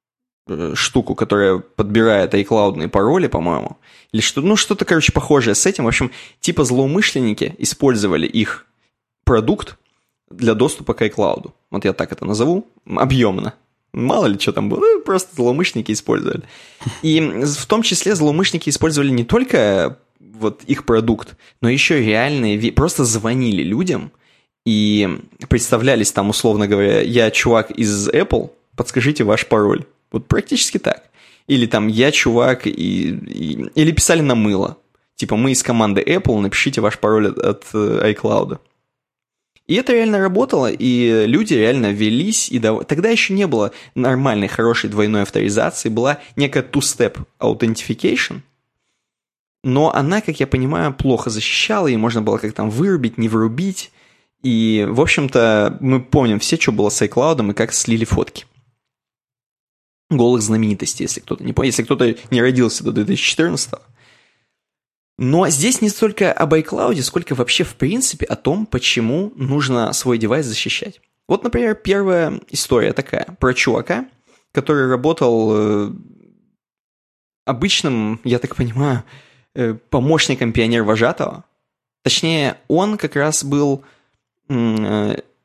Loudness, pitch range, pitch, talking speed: -17 LUFS, 110-155 Hz, 125 Hz, 135 wpm